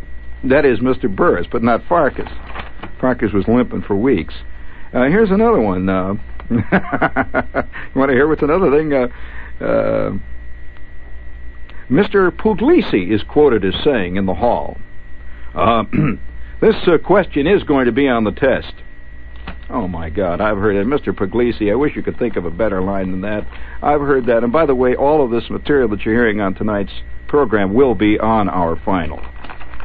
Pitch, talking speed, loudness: 95 Hz, 175 wpm, -16 LUFS